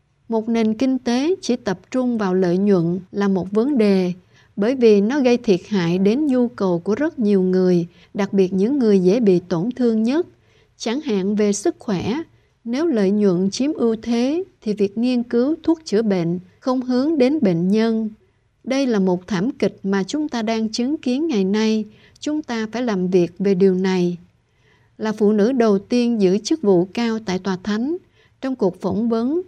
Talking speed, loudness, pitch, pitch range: 195 wpm, -19 LUFS, 215 Hz, 195-245 Hz